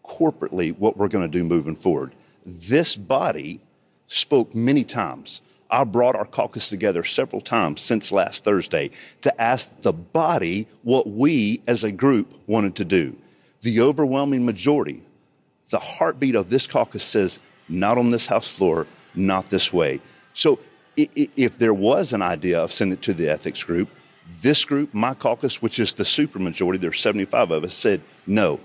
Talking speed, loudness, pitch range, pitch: 170 wpm, -22 LUFS, 95-140 Hz, 115 Hz